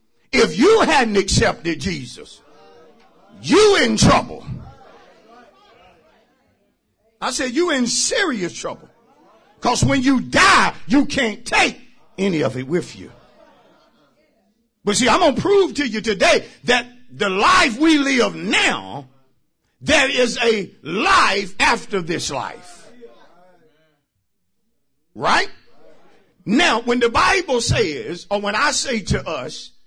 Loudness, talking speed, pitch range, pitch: -17 LUFS, 120 wpm, 185-270 Hz, 235 Hz